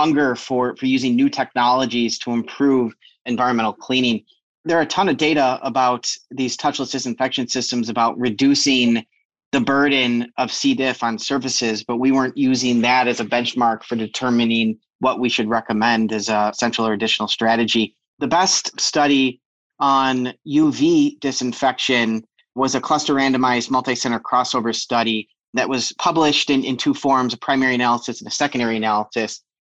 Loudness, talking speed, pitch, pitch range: -19 LUFS, 155 wpm, 125 Hz, 115-135 Hz